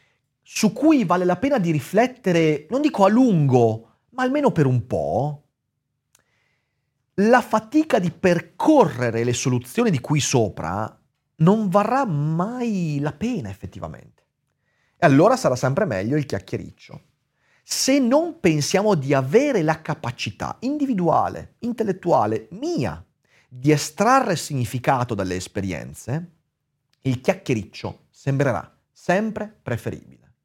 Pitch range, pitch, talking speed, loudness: 130-210 Hz, 155 Hz, 115 wpm, -21 LUFS